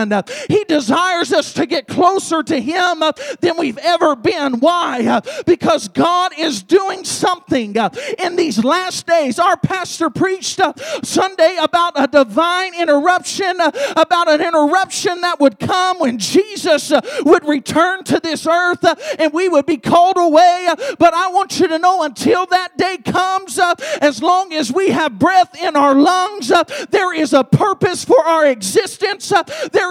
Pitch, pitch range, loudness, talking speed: 345 Hz, 305-365 Hz, -15 LUFS, 155 wpm